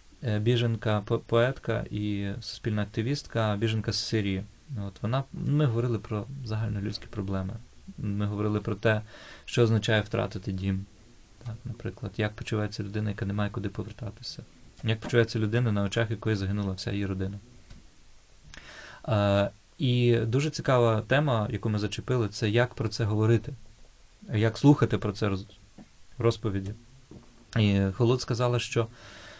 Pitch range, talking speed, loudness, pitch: 105-120 Hz, 135 wpm, -28 LUFS, 110 Hz